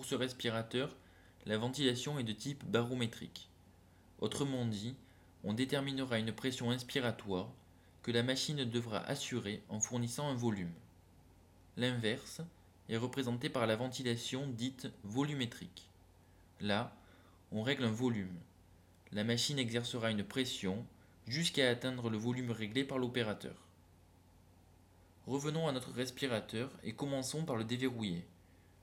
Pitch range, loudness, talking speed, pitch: 90-130 Hz, -38 LUFS, 125 wpm, 115 Hz